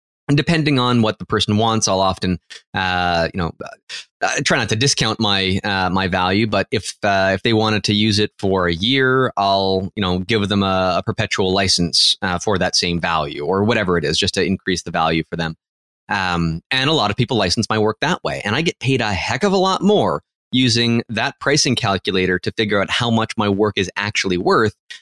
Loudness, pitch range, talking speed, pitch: -18 LUFS, 95-115 Hz, 225 wpm, 105 Hz